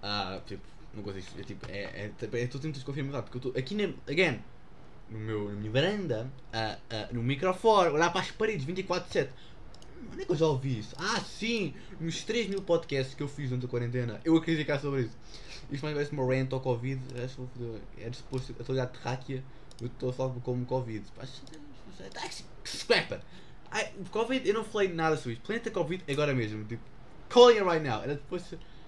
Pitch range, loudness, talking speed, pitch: 120-165 Hz, -31 LUFS, 205 wpm, 130 Hz